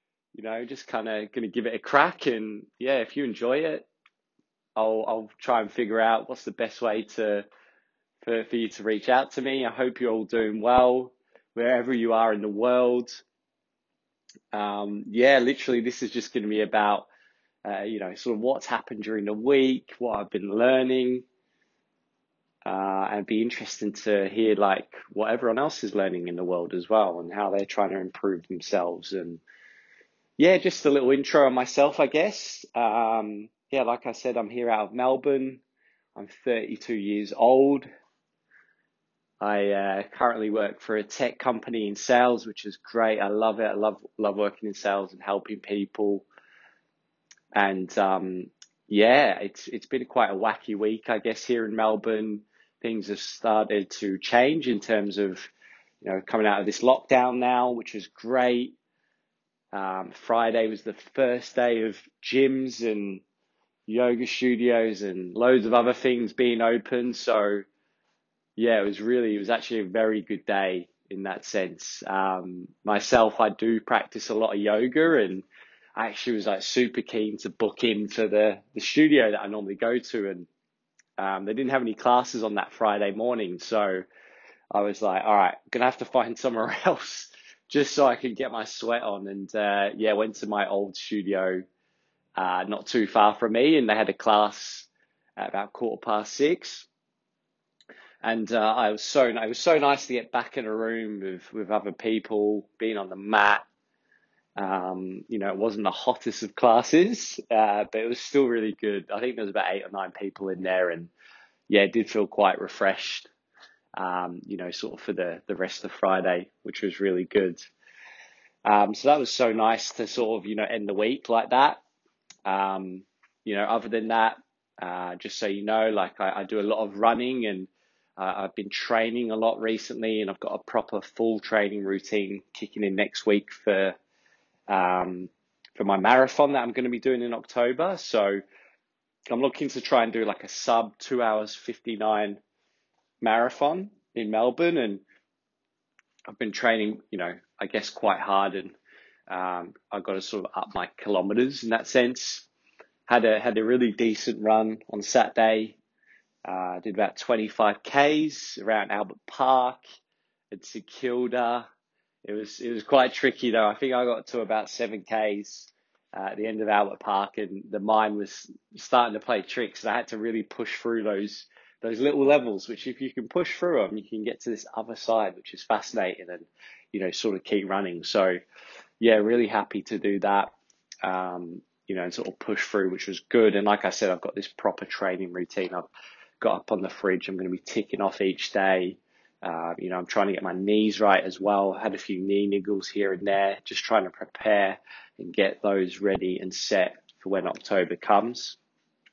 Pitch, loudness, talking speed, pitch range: 110 Hz, -26 LUFS, 190 wpm, 100-120 Hz